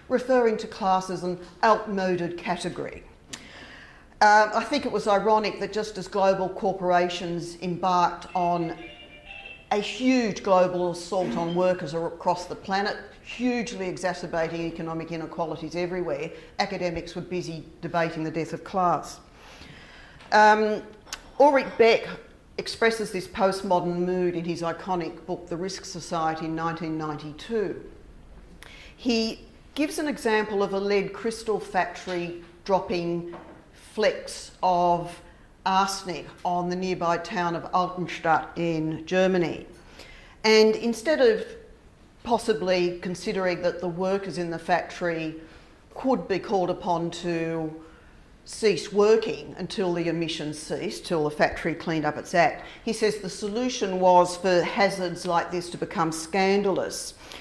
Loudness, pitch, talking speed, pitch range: -26 LUFS, 180 Hz, 125 wpm, 170-205 Hz